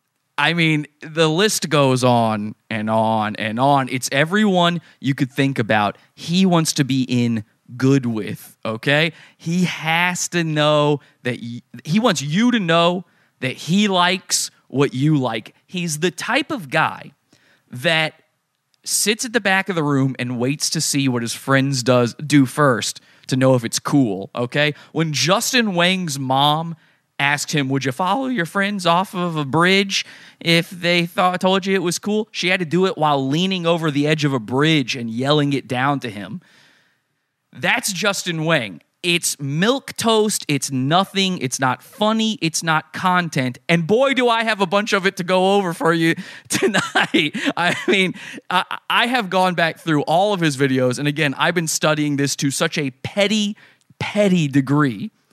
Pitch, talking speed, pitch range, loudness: 155 Hz, 180 wpm, 135-185 Hz, -18 LUFS